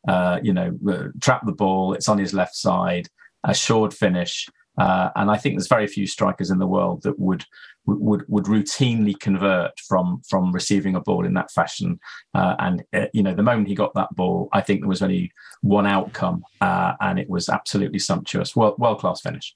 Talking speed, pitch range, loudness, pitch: 205 wpm, 95-105 Hz, -21 LUFS, 100 Hz